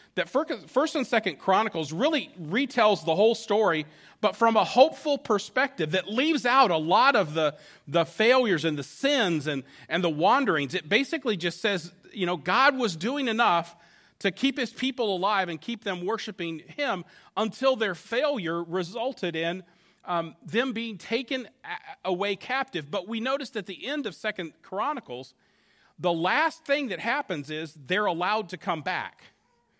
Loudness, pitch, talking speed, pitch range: -26 LUFS, 205 Hz, 165 wpm, 170-255 Hz